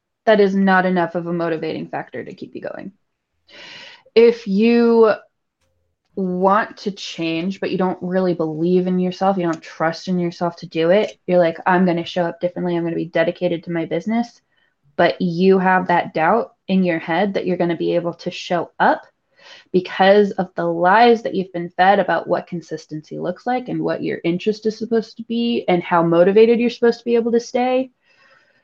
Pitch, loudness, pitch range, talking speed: 180 Hz, -18 LUFS, 170-220 Hz, 195 wpm